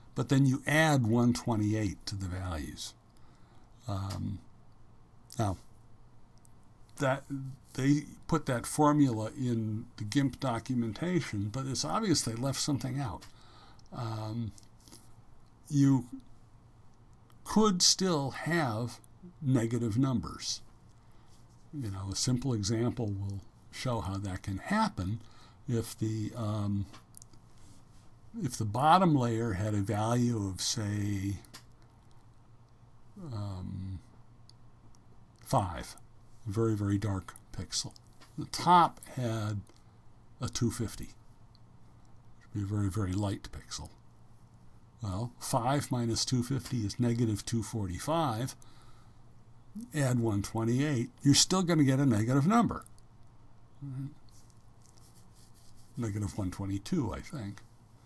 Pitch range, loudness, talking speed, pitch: 110-125 Hz, -31 LUFS, 105 wpm, 115 Hz